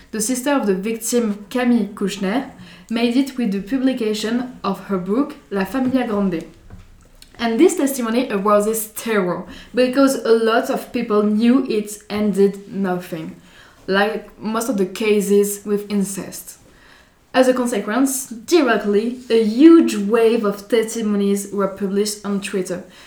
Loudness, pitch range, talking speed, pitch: -19 LUFS, 200-245 Hz, 135 wpm, 215 Hz